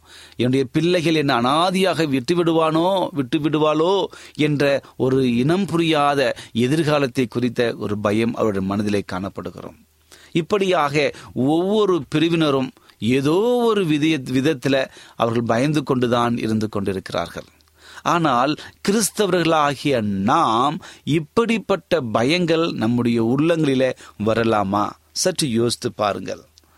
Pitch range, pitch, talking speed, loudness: 115-165 Hz, 140 Hz, 95 wpm, -20 LUFS